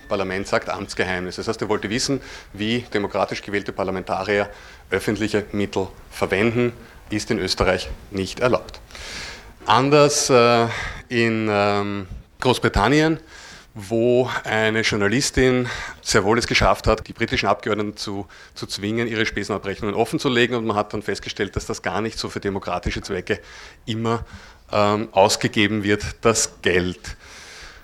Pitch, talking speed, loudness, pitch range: 105 Hz, 130 wpm, -21 LUFS, 100-115 Hz